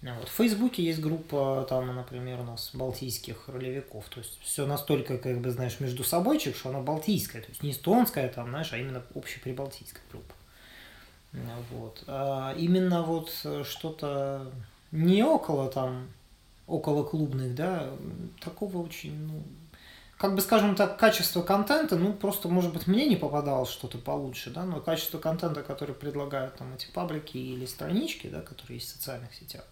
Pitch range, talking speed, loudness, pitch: 125-165 Hz, 160 wpm, -30 LUFS, 140 Hz